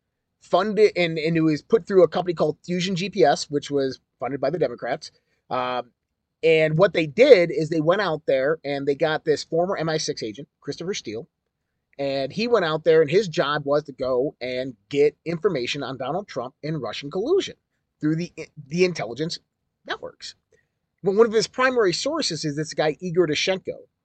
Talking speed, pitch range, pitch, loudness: 180 wpm, 145-190 Hz, 160 Hz, -23 LUFS